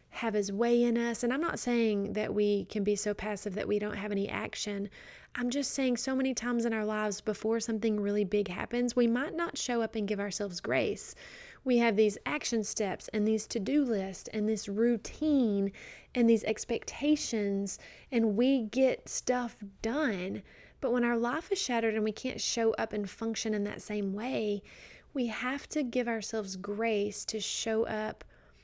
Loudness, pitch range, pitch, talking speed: -32 LUFS, 210-245 Hz, 220 Hz, 190 wpm